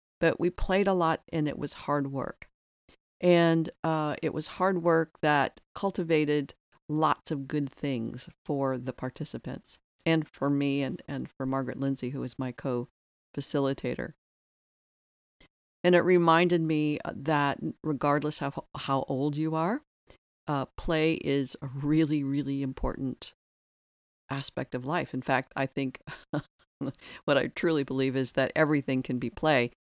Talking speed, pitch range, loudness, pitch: 145 wpm, 135-160 Hz, -29 LUFS, 145 Hz